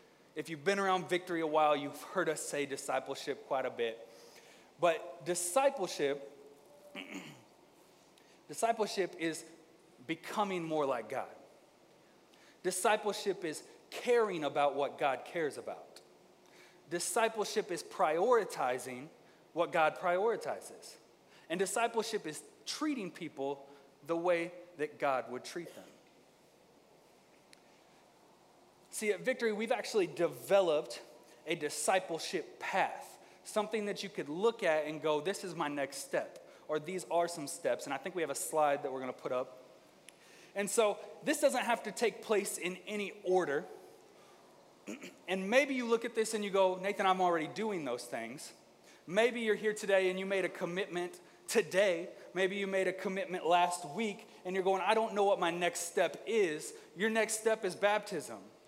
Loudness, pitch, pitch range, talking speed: -34 LUFS, 185 Hz, 160-215 Hz, 150 wpm